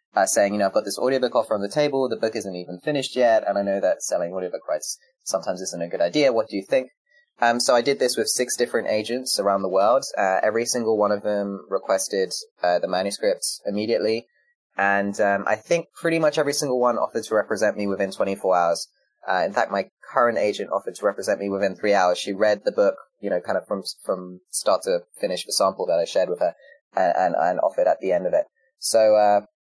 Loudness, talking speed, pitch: -22 LUFS, 235 wpm, 120 Hz